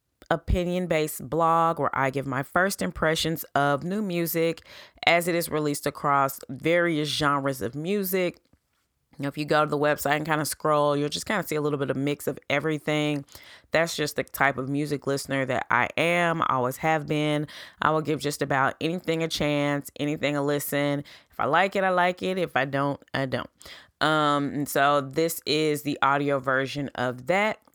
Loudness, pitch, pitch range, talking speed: -25 LUFS, 150 Hz, 140-165 Hz, 195 wpm